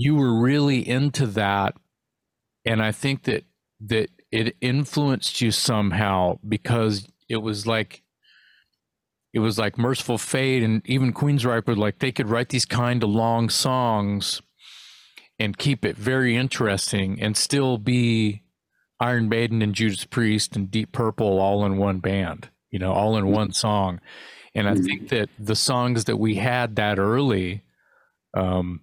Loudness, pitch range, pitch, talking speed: -23 LUFS, 100-125 Hz, 110 Hz, 155 wpm